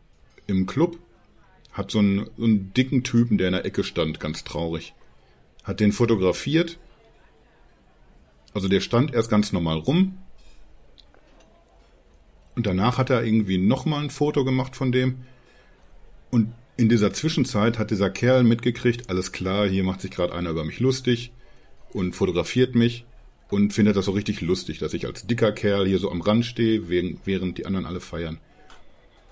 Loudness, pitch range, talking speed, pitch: -23 LUFS, 90-125 Hz, 160 wpm, 105 Hz